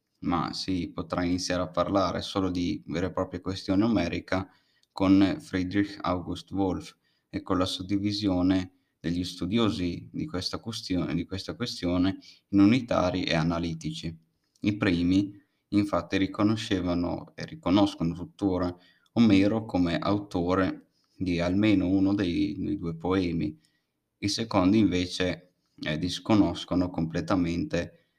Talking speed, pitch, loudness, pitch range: 120 wpm, 90 Hz, -28 LUFS, 85-100 Hz